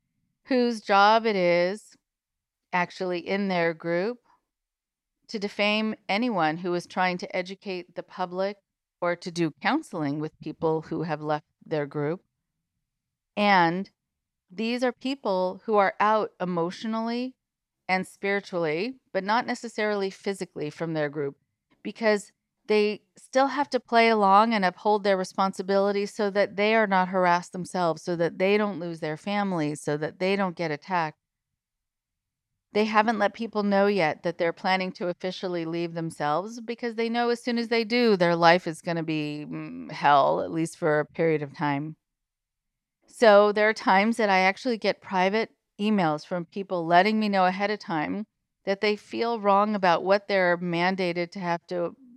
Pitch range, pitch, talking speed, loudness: 170-210 Hz, 190 Hz, 165 wpm, -25 LUFS